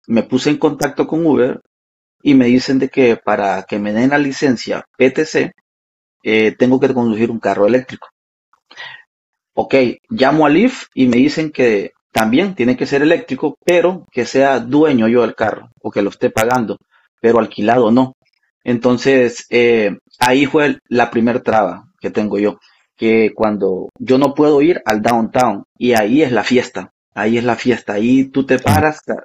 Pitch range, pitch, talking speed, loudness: 110-135 Hz, 125 Hz, 170 wpm, -14 LUFS